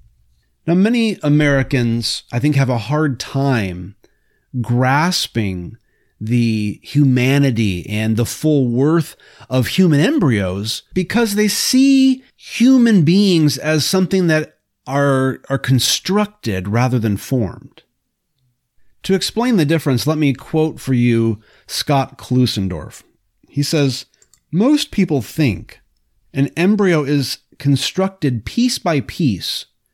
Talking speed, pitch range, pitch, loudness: 110 wpm, 115-165 Hz, 135 Hz, -16 LUFS